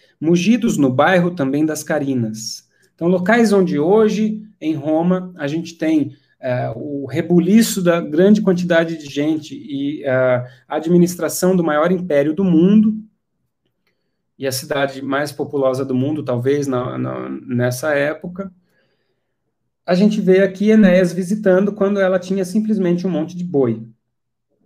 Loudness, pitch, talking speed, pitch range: -17 LUFS, 165 Hz, 140 wpm, 140-190 Hz